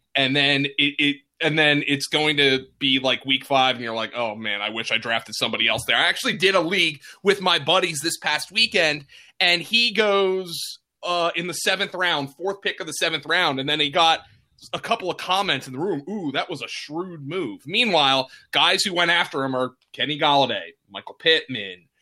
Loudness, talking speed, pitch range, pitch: -21 LUFS, 215 wpm, 135-185 Hz, 155 Hz